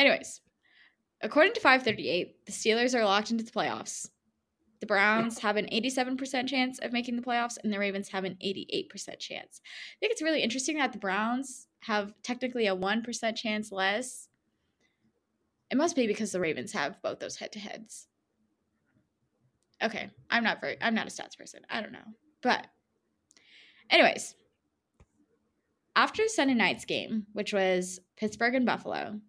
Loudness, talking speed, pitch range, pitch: -29 LUFS, 155 wpm, 210-255 Hz, 225 Hz